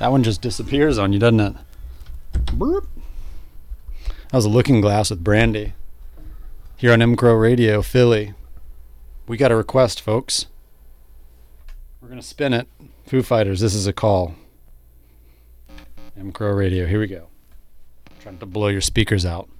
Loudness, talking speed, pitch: -18 LUFS, 145 wpm, 95 Hz